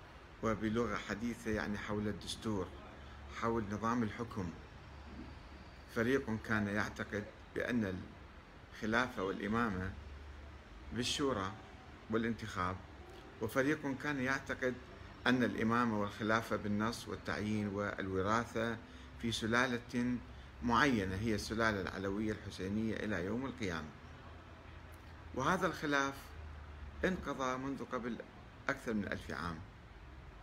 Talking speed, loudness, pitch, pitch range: 85 wpm, -38 LUFS, 105 Hz, 85-115 Hz